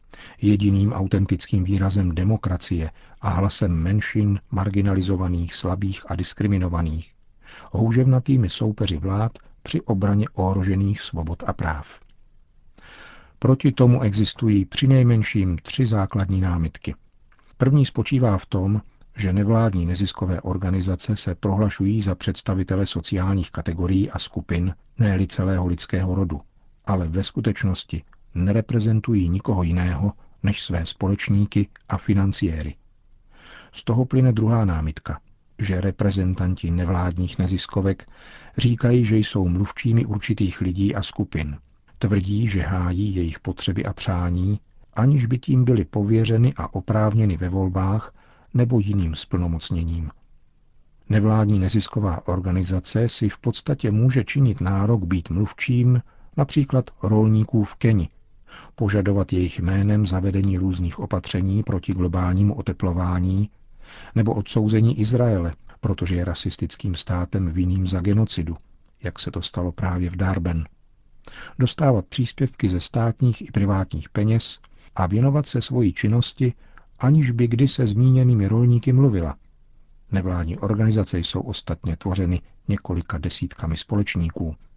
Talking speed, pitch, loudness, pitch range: 115 wpm, 100 Hz, -22 LUFS, 90-110 Hz